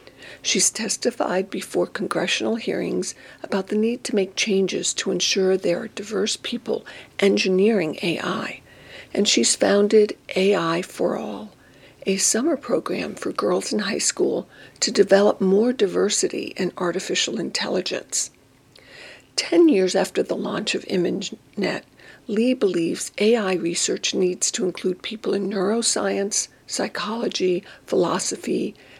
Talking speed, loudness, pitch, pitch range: 120 wpm, -22 LUFS, 200 Hz, 185-220 Hz